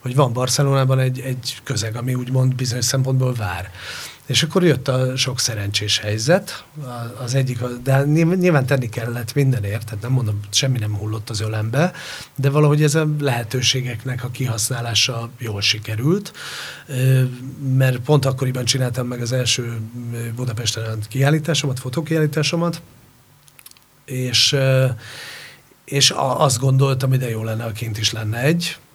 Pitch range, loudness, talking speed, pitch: 120-140 Hz, -19 LUFS, 135 wpm, 130 Hz